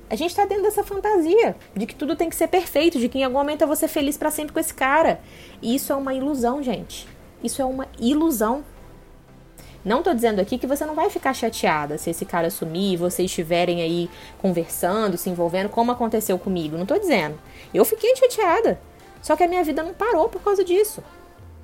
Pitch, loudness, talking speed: 265 Hz, -22 LUFS, 215 wpm